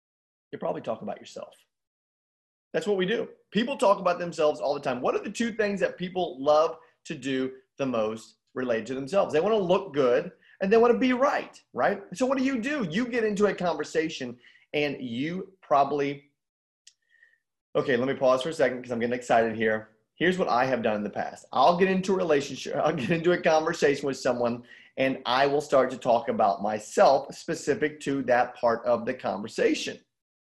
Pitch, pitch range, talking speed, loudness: 155 Hz, 125-200 Hz, 200 wpm, -26 LUFS